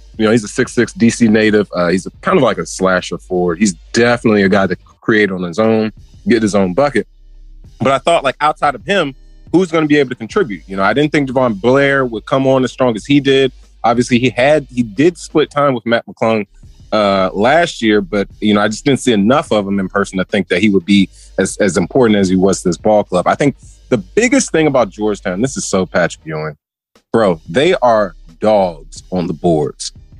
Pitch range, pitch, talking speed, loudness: 95-130 Hz, 110 Hz, 235 wpm, -14 LUFS